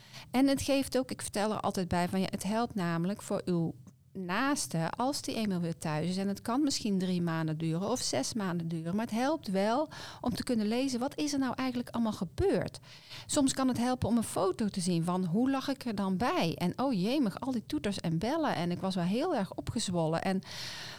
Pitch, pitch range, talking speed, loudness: 205 Hz, 180-250 Hz, 230 wpm, -32 LUFS